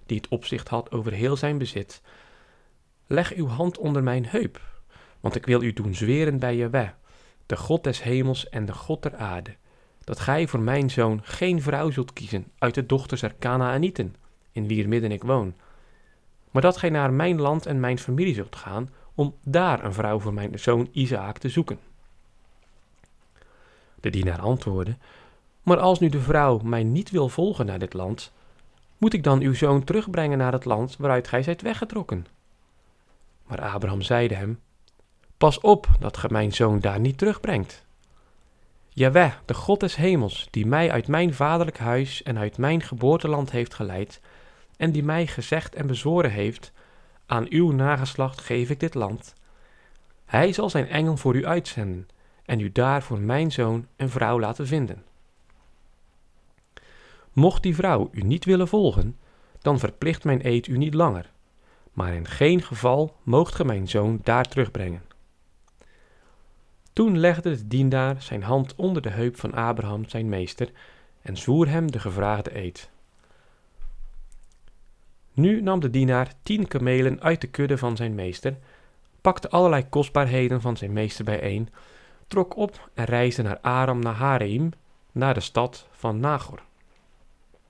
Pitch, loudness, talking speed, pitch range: 125 Hz, -24 LUFS, 160 wpm, 105-150 Hz